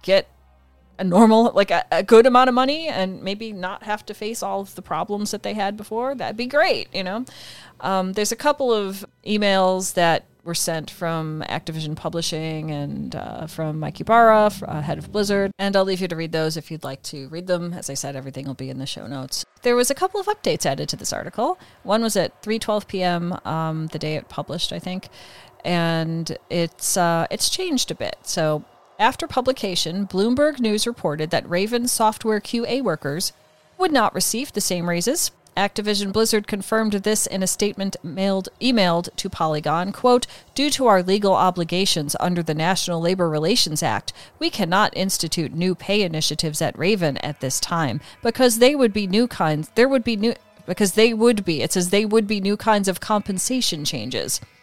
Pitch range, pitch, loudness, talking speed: 165-220 Hz, 190 Hz, -21 LUFS, 195 wpm